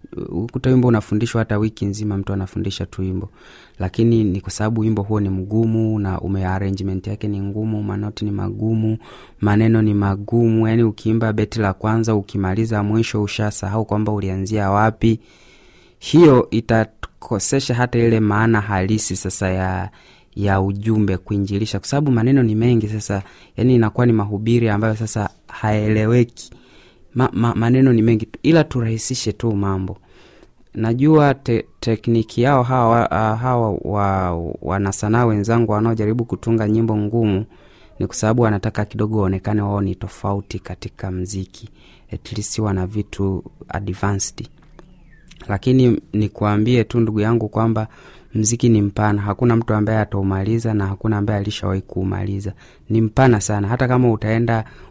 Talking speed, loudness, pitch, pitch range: 130 wpm, -19 LUFS, 110 Hz, 100-115 Hz